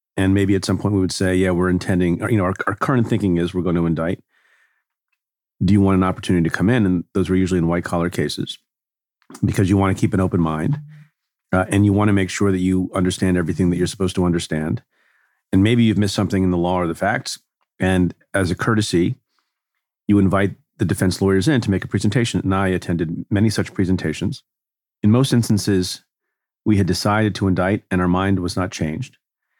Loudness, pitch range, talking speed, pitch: -19 LUFS, 90-105 Hz, 220 wpm, 95 Hz